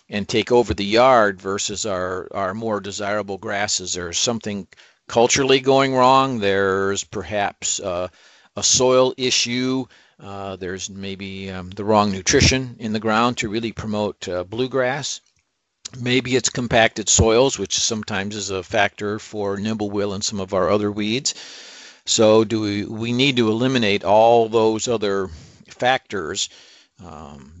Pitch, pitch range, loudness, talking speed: 105 Hz, 100-120 Hz, -19 LUFS, 145 wpm